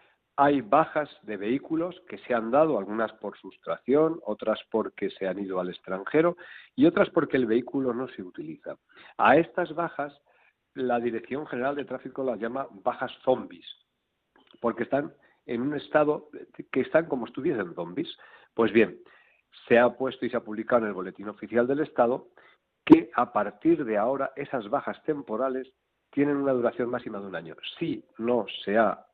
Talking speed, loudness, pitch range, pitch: 170 wpm, -27 LUFS, 115-145 Hz, 130 Hz